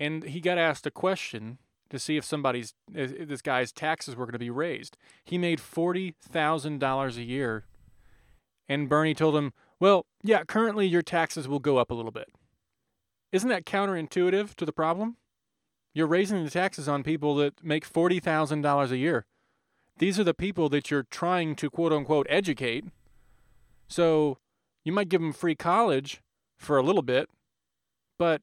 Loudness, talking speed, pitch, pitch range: -27 LUFS, 165 wpm, 155 Hz, 140-175 Hz